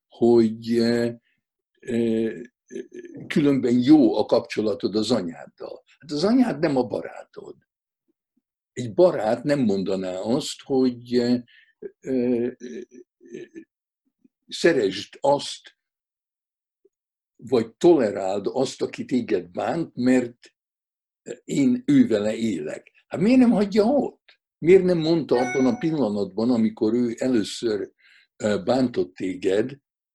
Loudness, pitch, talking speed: -22 LUFS, 175 Hz, 95 wpm